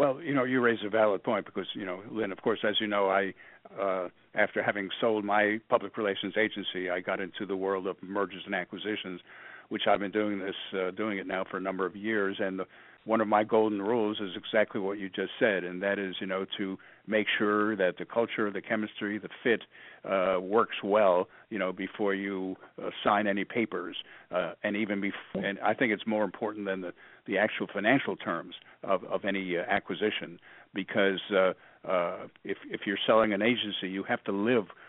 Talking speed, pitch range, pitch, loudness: 210 wpm, 95-105 Hz, 100 Hz, -30 LUFS